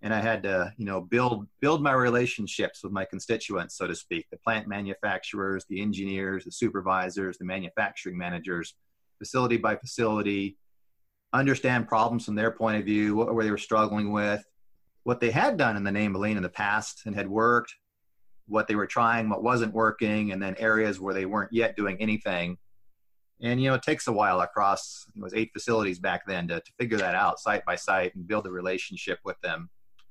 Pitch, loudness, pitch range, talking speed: 105 Hz, -28 LUFS, 95-115 Hz, 200 wpm